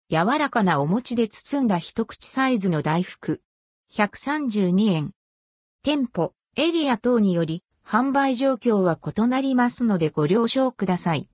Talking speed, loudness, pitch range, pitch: 250 characters per minute, -23 LUFS, 180-260 Hz, 225 Hz